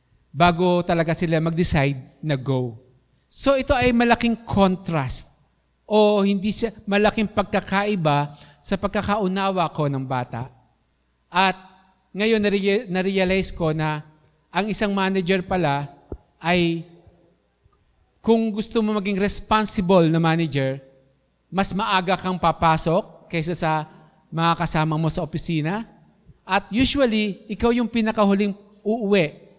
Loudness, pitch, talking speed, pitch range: -21 LUFS, 185 Hz, 110 wpm, 155-205 Hz